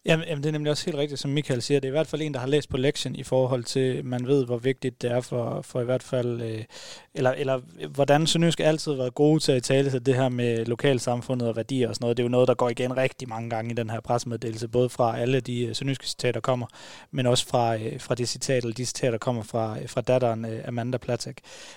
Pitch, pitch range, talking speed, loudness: 125 Hz, 120-140 Hz, 255 wpm, -26 LUFS